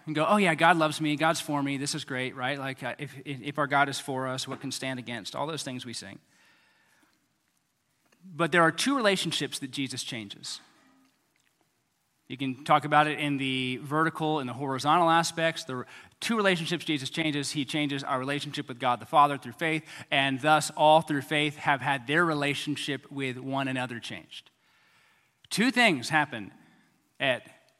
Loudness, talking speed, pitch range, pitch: -27 LUFS, 180 wpm, 130-155 Hz, 145 Hz